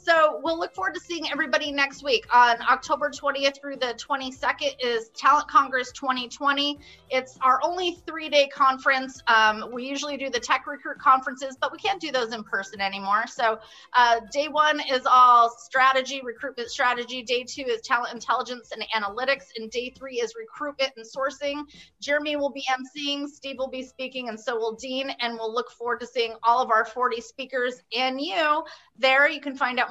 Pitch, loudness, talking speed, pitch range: 265 Hz, -24 LUFS, 185 wpm, 245-290 Hz